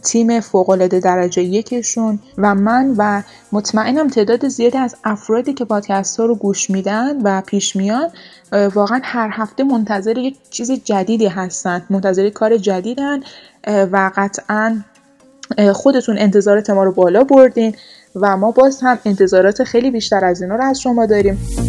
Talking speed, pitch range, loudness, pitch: 150 wpm, 200-245 Hz, -15 LUFS, 215 Hz